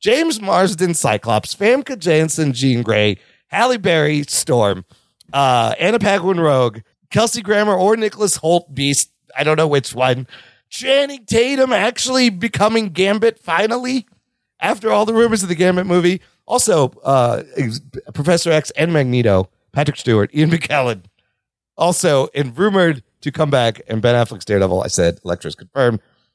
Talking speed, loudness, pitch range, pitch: 145 wpm, -16 LUFS, 125-210 Hz, 160 Hz